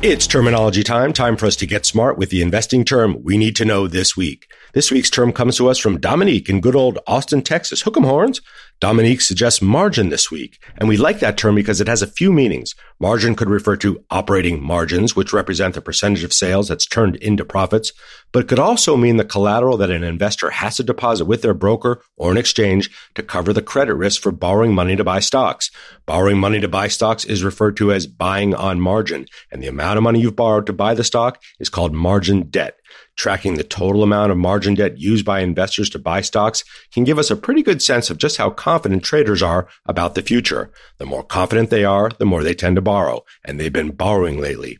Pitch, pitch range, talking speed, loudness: 105 Hz, 95-115 Hz, 225 wpm, -16 LUFS